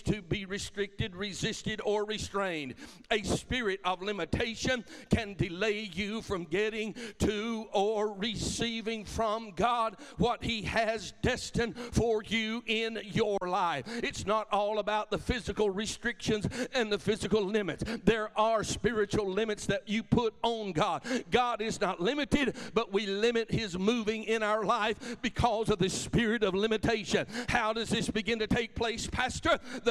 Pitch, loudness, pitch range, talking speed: 215 Hz, -31 LUFS, 205-225 Hz, 155 wpm